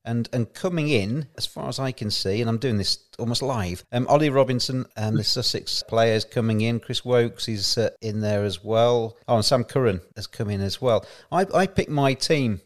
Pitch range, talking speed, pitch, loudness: 110-130 Hz, 230 wpm, 115 Hz, -23 LUFS